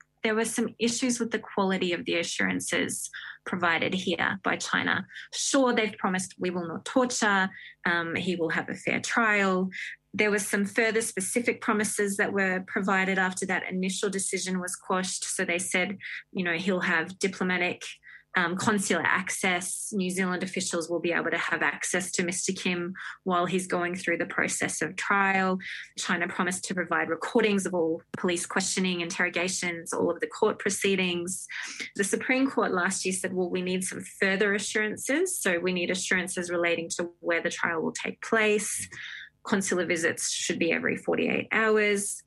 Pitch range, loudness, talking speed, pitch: 180-210 Hz, -27 LUFS, 170 wpm, 190 Hz